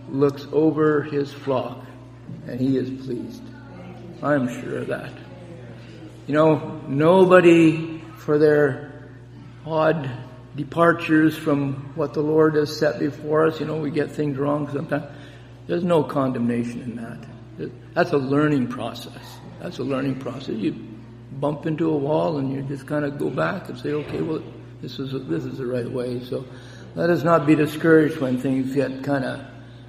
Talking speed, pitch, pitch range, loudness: 165 wpm, 140 Hz, 125-150 Hz, -22 LUFS